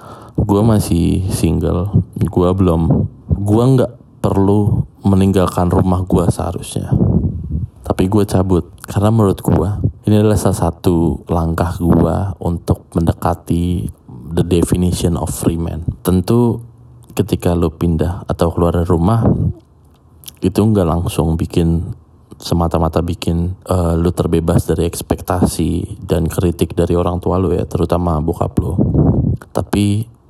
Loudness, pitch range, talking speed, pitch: -16 LUFS, 85-105 Hz, 120 wpm, 90 Hz